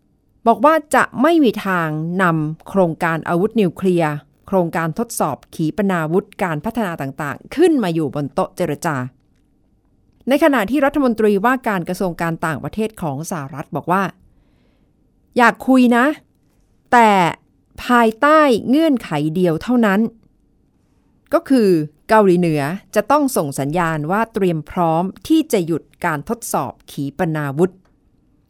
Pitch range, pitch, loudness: 155-230 Hz, 185 Hz, -17 LUFS